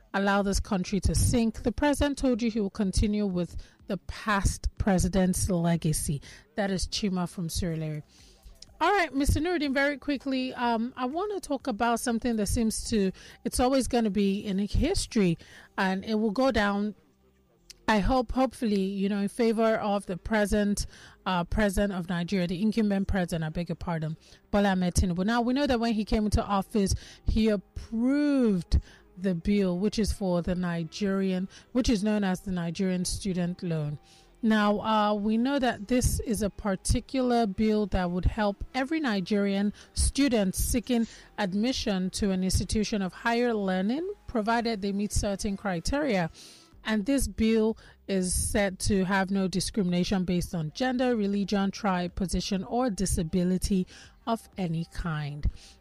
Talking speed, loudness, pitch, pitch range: 155 wpm, -28 LUFS, 205 Hz, 185-230 Hz